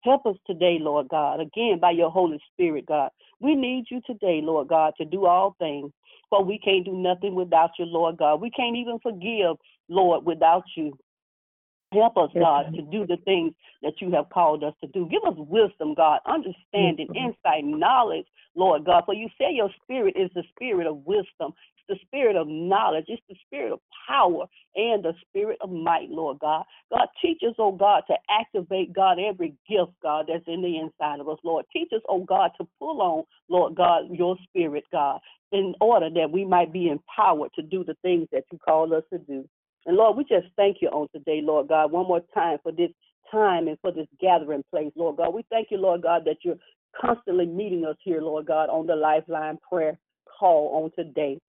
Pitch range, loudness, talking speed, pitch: 160-200 Hz, -24 LUFS, 205 wpm, 175 Hz